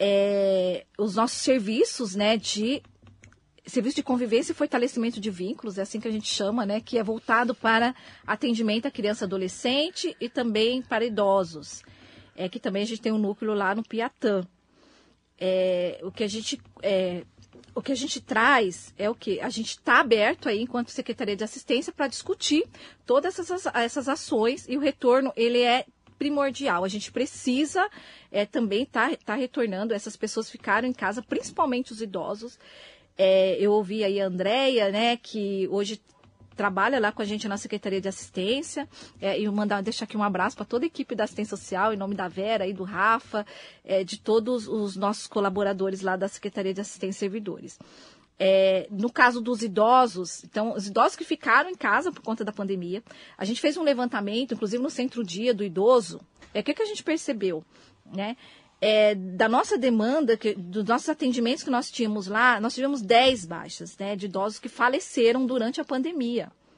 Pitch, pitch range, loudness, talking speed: 225 Hz, 200-255 Hz, -26 LUFS, 185 wpm